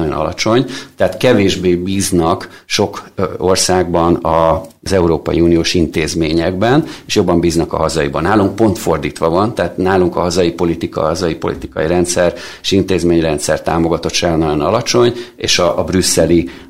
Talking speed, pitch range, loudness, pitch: 130 wpm, 85-95 Hz, -14 LUFS, 90 Hz